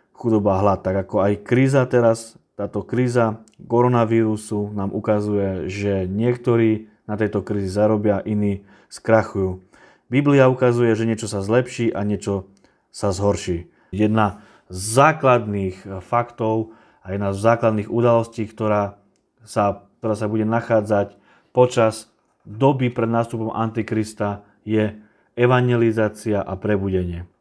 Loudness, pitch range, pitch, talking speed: -20 LUFS, 100-115 Hz, 110 Hz, 120 wpm